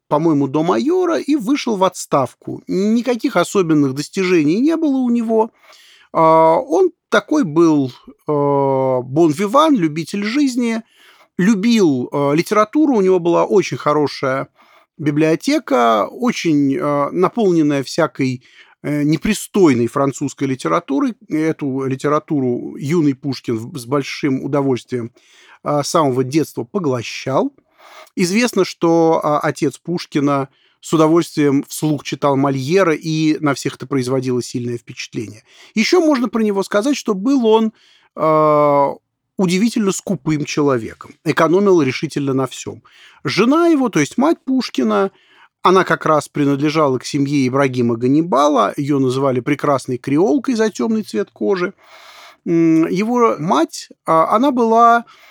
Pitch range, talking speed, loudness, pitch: 140-220 Hz, 115 wpm, -16 LUFS, 160 Hz